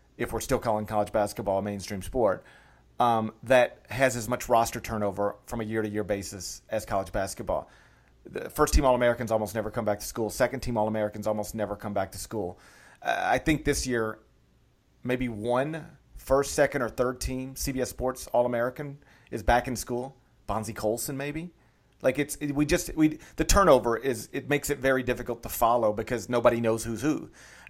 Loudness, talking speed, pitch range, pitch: -28 LUFS, 195 wpm, 110-130 Hz, 120 Hz